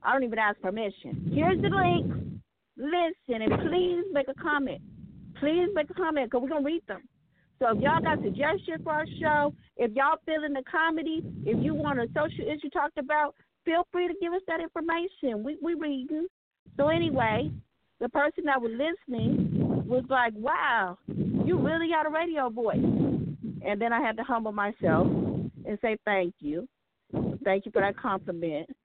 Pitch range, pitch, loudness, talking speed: 230-320 Hz, 285 Hz, -28 LUFS, 185 wpm